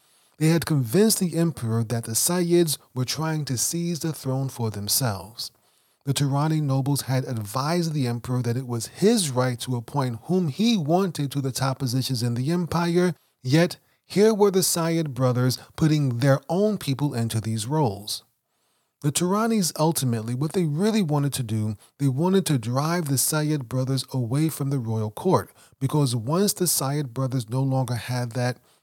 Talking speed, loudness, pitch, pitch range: 175 wpm, -24 LUFS, 140 Hz, 125-165 Hz